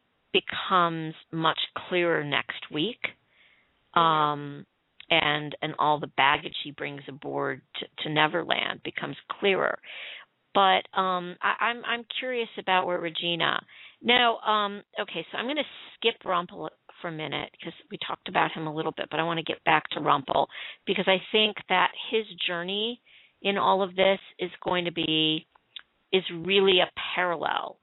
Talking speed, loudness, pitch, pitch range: 160 wpm, -26 LUFS, 180 Hz, 160-200 Hz